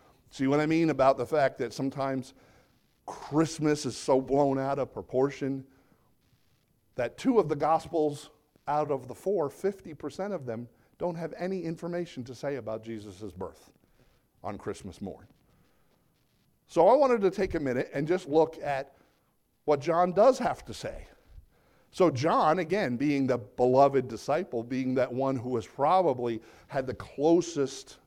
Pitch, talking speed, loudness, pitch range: 140 Hz, 155 wpm, -28 LUFS, 130-165 Hz